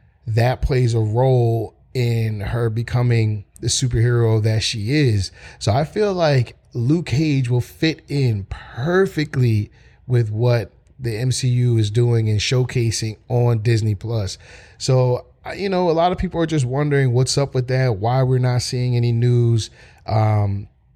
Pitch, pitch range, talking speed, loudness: 120 Hz, 110-130 Hz, 160 wpm, -19 LUFS